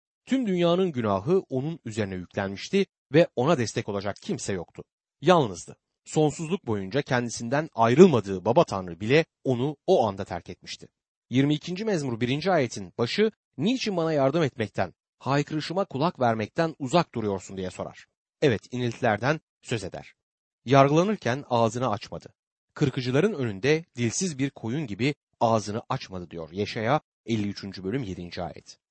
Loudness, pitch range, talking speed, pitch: -26 LUFS, 105-155 Hz, 130 wpm, 125 Hz